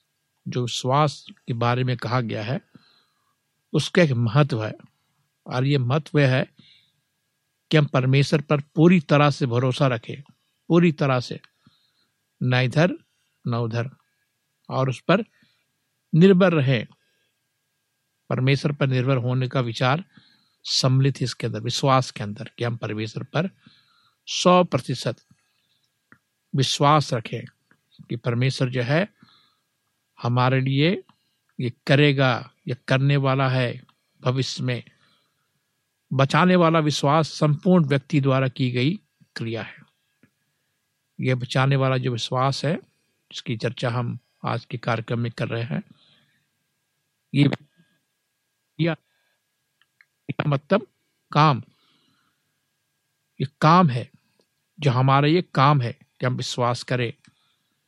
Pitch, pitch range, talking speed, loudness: 135 Hz, 125-150 Hz, 115 wpm, -22 LUFS